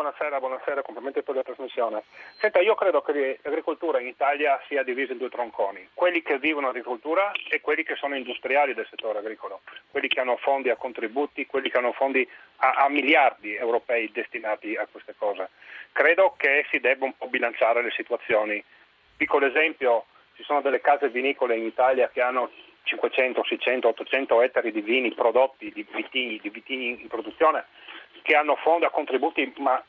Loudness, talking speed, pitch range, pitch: -25 LUFS, 175 wpm, 125-150 Hz, 135 Hz